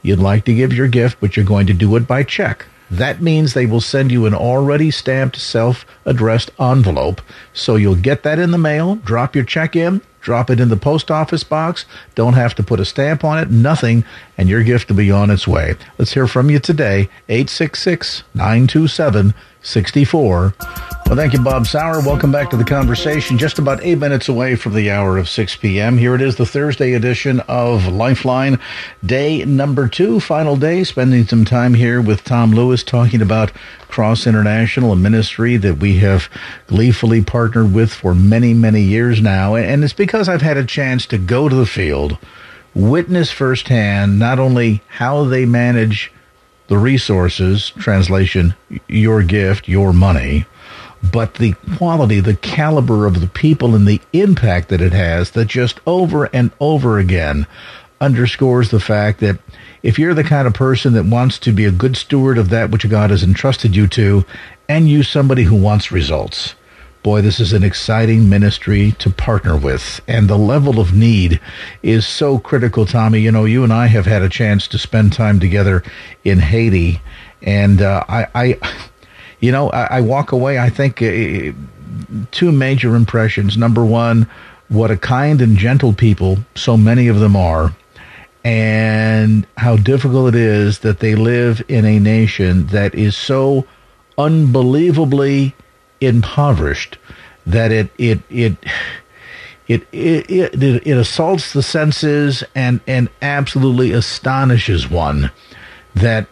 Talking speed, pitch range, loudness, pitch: 165 wpm, 105-130 Hz, -14 LUFS, 115 Hz